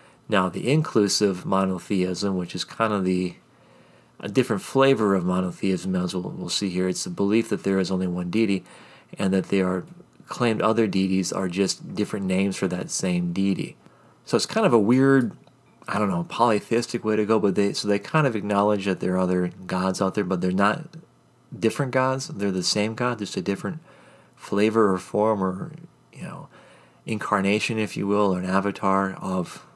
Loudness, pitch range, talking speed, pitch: -24 LUFS, 95-110 Hz, 195 wpm, 100 Hz